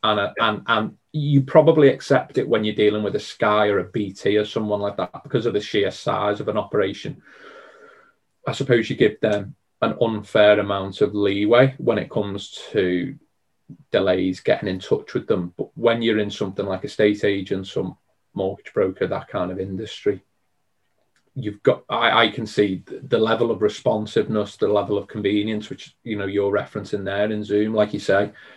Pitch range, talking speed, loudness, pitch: 100-115 Hz, 190 wpm, -21 LUFS, 105 Hz